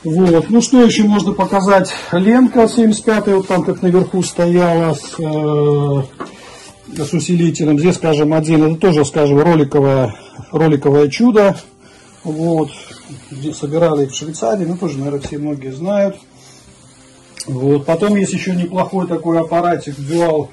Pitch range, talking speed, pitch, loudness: 150-190 Hz, 130 wpm, 165 Hz, -14 LUFS